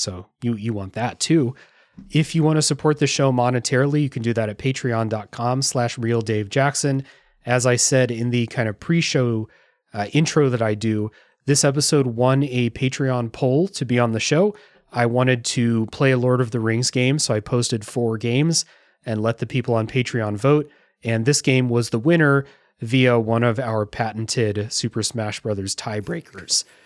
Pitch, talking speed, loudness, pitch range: 125 Hz, 190 wpm, -21 LUFS, 115-140 Hz